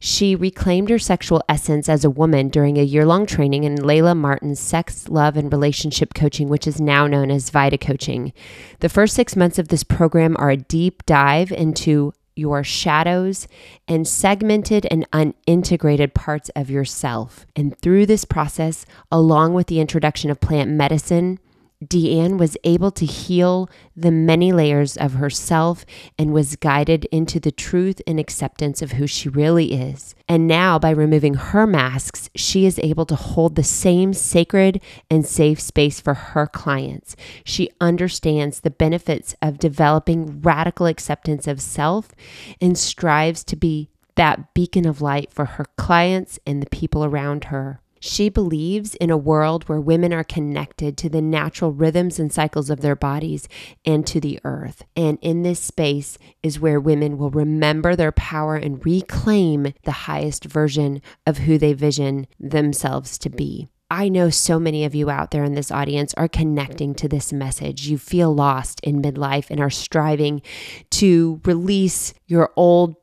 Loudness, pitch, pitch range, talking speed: -19 LUFS, 155 Hz, 145-170 Hz, 165 wpm